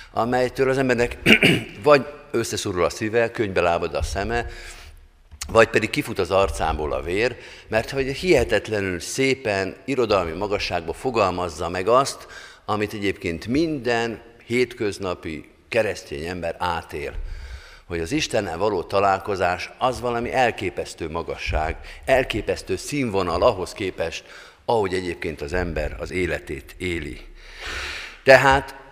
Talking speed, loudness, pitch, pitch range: 115 wpm, -22 LUFS, 100 Hz, 85-120 Hz